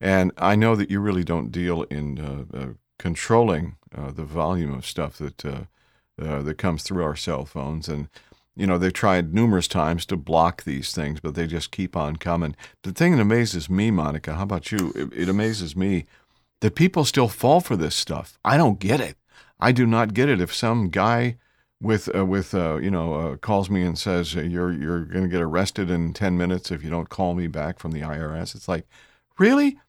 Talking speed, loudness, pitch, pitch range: 215 wpm, -23 LUFS, 90 Hz, 80-100 Hz